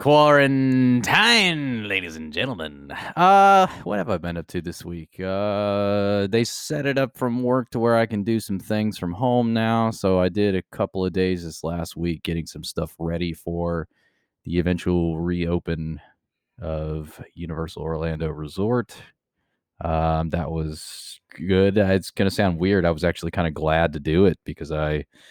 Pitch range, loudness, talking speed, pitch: 80-110 Hz, -22 LUFS, 170 wpm, 90 Hz